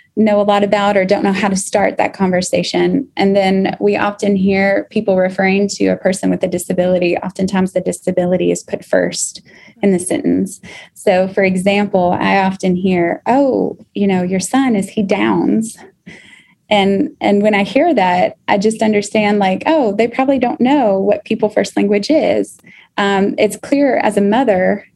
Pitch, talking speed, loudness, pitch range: 200 Hz, 180 wpm, -14 LUFS, 190-215 Hz